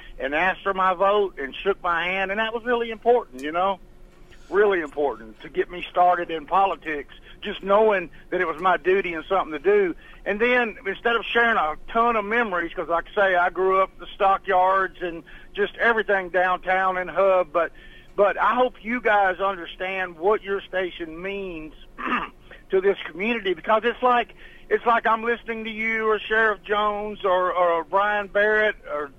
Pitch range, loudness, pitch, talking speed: 180-225 Hz, -23 LUFS, 195 Hz, 185 wpm